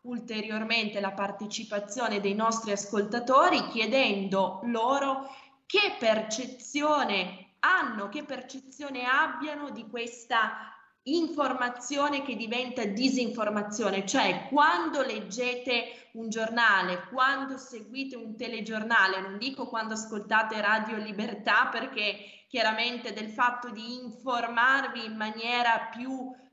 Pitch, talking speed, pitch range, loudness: 235 Hz, 100 wpm, 215-260 Hz, -28 LUFS